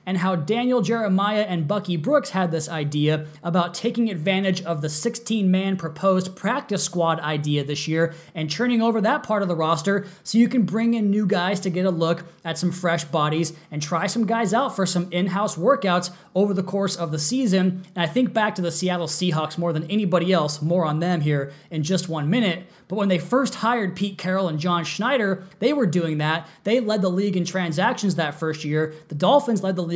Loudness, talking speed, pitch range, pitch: -23 LUFS, 215 wpm, 165-205 Hz, 185 Hz